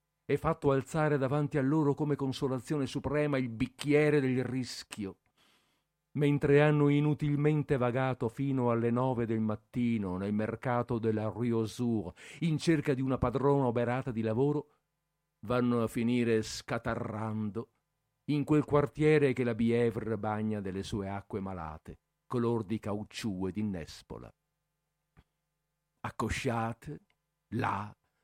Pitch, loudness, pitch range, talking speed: 125 Hz, -31 LUFS, 110-145 Hz, 115 wpm